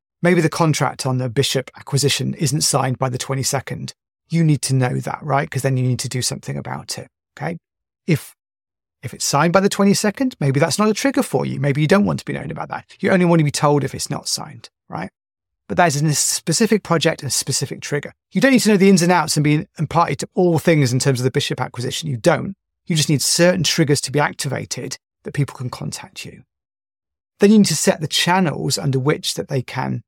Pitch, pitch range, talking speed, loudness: 150 Hz, 135-175 Hz, 245 wpm, -18 LUFS